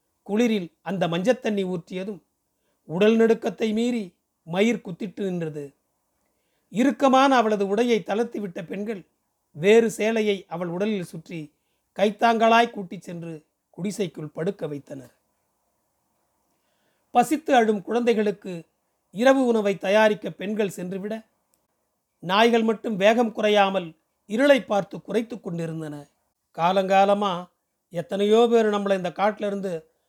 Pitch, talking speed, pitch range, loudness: 205 Hz, 100 wpm, 180-225 Hz, -23 LUFS